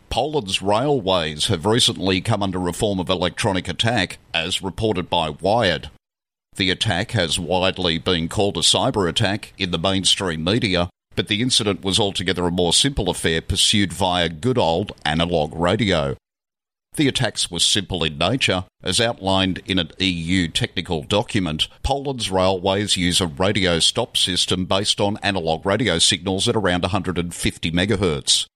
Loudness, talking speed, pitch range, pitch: -20 LUFS, 150 wpm, 90-105 Hz, 95 Hz